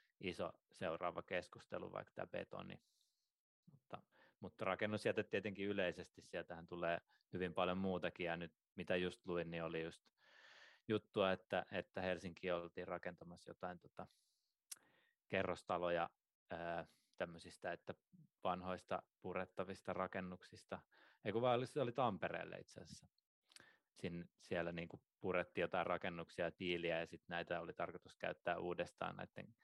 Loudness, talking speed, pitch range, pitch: -45 LUFS, 125 wpm, 85-95 Hz, 90 Hz